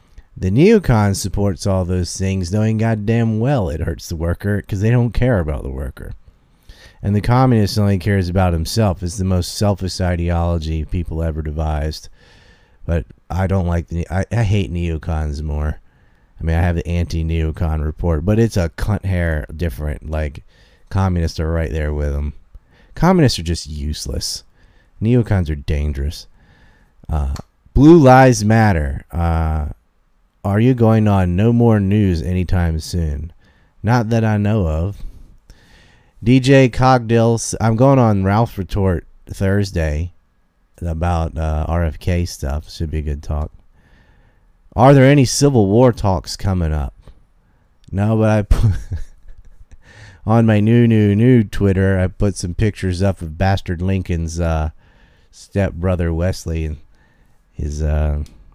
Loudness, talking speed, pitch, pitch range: -17 LUFS, 140 wpm, 90 Hz, 80-105 Hz